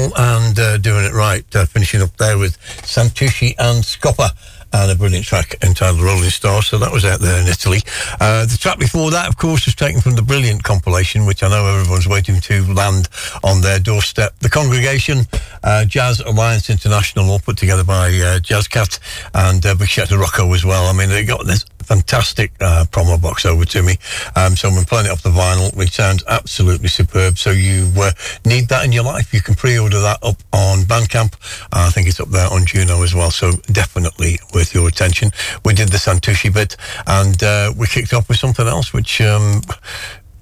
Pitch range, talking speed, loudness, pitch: 95-115 Hz, 205 wpm, -14 LUFS, 100 Hz